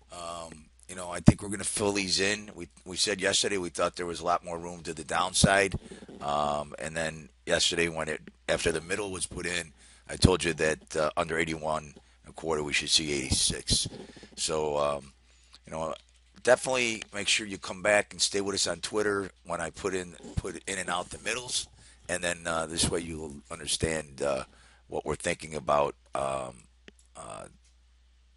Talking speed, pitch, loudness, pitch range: 200 wpm, 85 Hz, -29 LUFS, 75-90 Hz